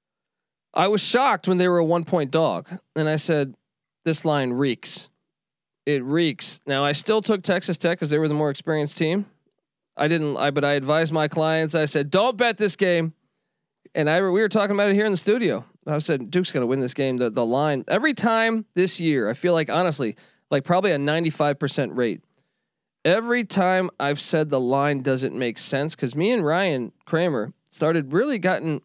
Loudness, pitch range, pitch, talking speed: -22 LUFS, 145-185 Hz, 160 Hz, 200 wpm